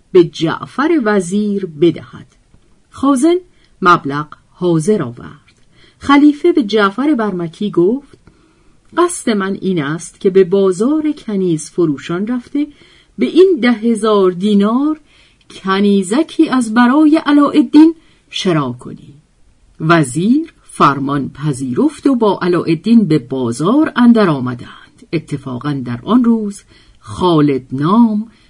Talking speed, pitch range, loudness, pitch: 105 wpm, 155-255 Hz, -13 LUFS, 195 Hz